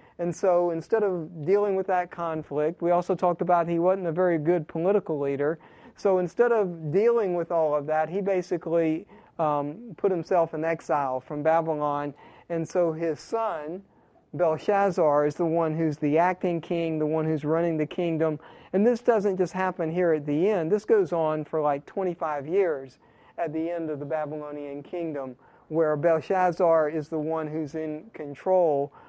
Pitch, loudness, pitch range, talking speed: 165 Hz, -26 LUFS, 155-185 Hz, 175 wpm